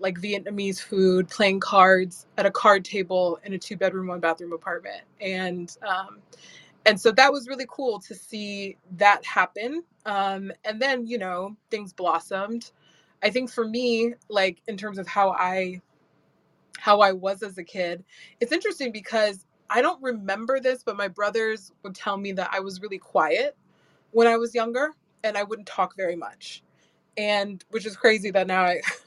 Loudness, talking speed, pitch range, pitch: -24 LUFS, 175 wpm, 185-225 Hz, 200 Hz